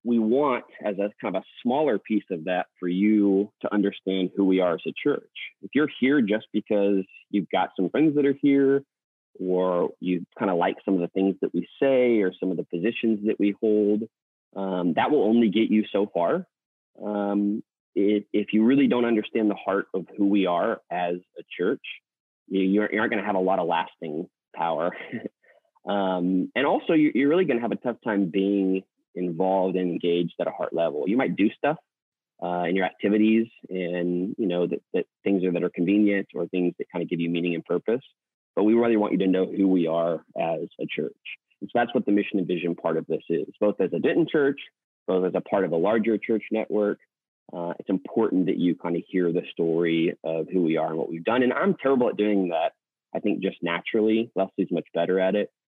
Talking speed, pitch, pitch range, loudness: 225 wpm, 100 Hz, 90-110 Hz, -25 LUFS